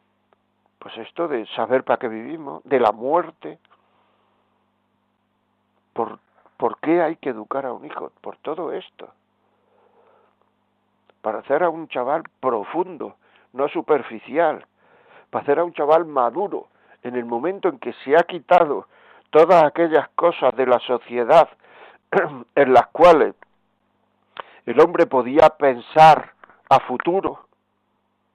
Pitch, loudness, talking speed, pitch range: 145 Hz, -19 LUFS, 125 wpm, 125-170 Hz